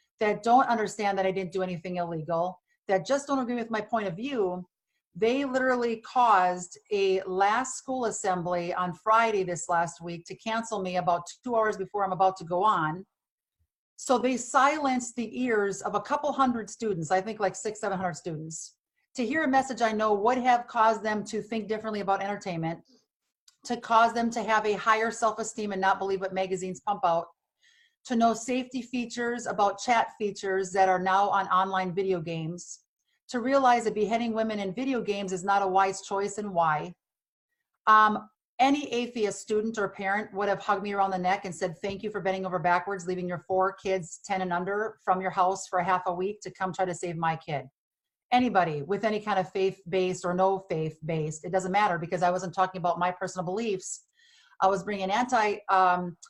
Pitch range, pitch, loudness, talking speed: 185-225 Hz, 200 Hz, -28 LUFS, 200 wpm